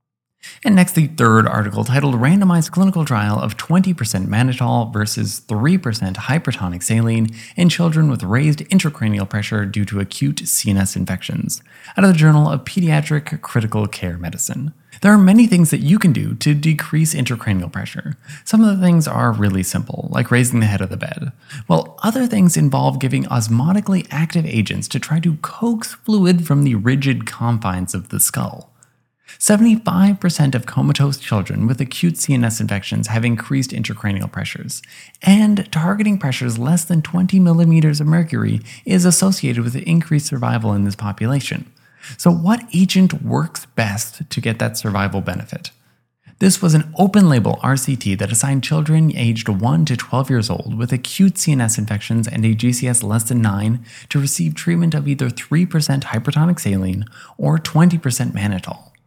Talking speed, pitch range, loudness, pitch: 160 wpm, 115-165 Hz, -17 LUFS, 135 Hz